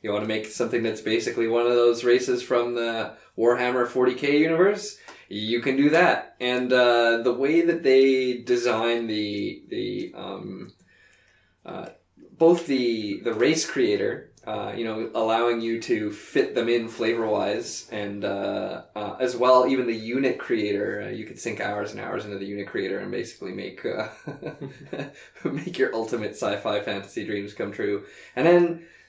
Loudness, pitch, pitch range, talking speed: -24 LUFS, 120 Hz, 115-135 Hz, 170 wpm